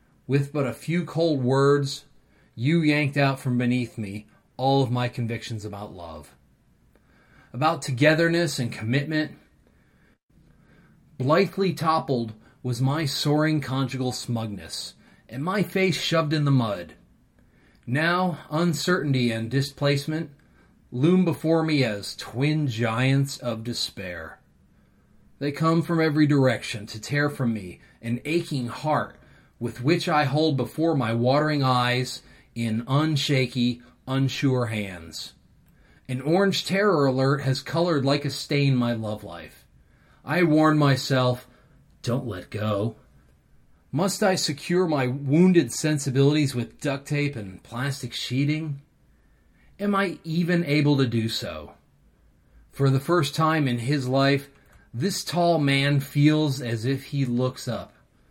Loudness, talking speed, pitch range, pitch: -24 LUFS, 130 wpm, 120-155 Hz, 140 Hz